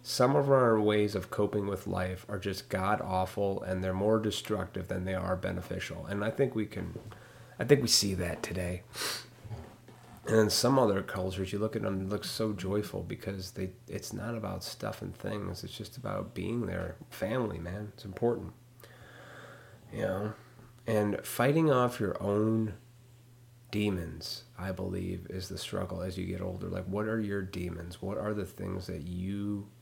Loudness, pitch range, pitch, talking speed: -32 LUFS, 95-115 Hz, 105 Hz, 180 wpm